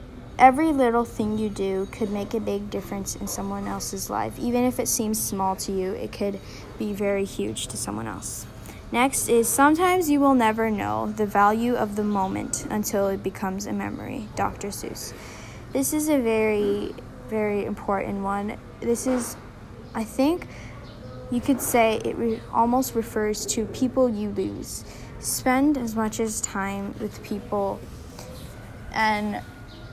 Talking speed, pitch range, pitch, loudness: 155 wpm, 190-235 Hz, 210 Hz, -25 LUFS